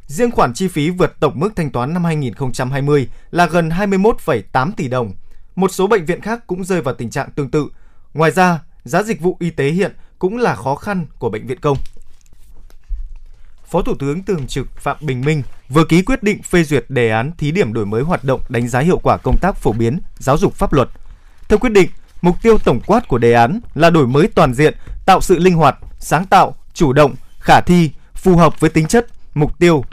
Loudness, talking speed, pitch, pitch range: -15 LUFS, 220 wpm, 155 Hz, 125-180 Hz